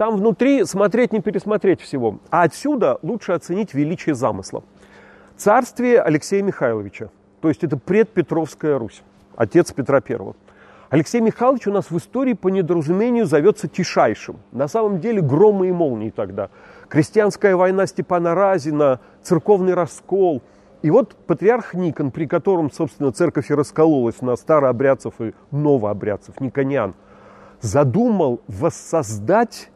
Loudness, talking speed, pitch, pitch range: -19 LUFS, 125 wpm, 170 Hz, 140-200 Hz